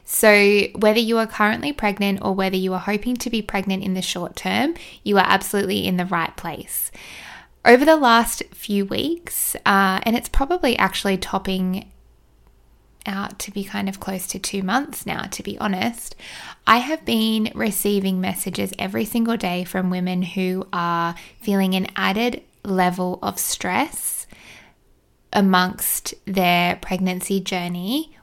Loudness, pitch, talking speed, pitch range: -21 LUFS, 200 Hz, 150 wpm, 185-225 Hz